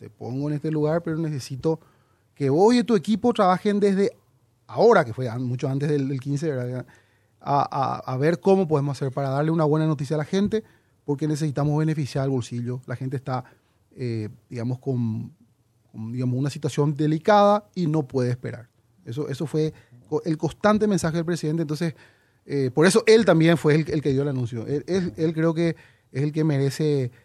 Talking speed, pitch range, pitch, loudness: 190 wpm, 125-160 Hz, 145 Hz, -23 LUFS